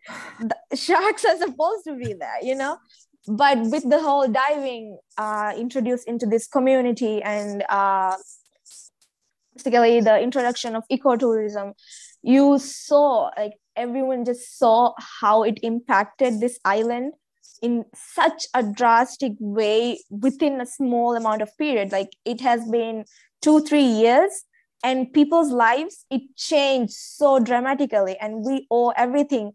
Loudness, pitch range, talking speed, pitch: -21 LUFS, 225-280 Hz, 135 wpm, 245 Hz